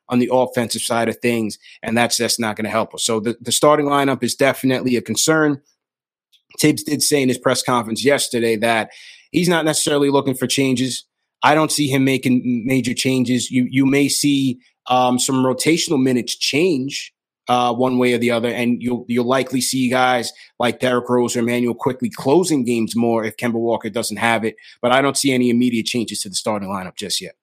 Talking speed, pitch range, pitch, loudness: 205 wpm, 120-135 Hz, 125 Hz, -18 LUFS